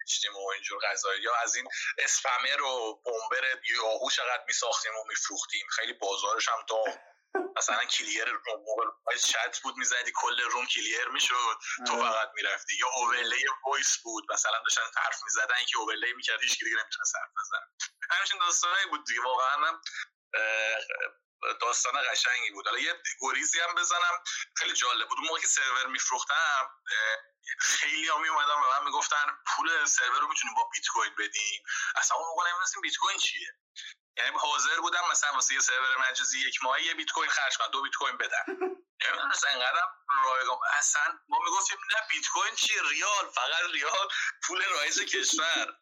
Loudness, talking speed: -28 LUFS, 165 wpm